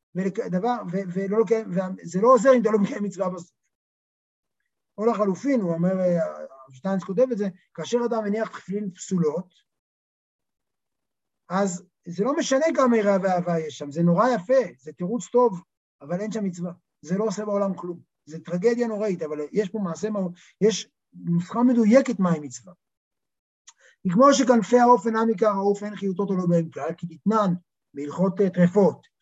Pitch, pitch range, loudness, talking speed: 195 Hz, 170-220 Hz, -23 LUFS, 160 wpm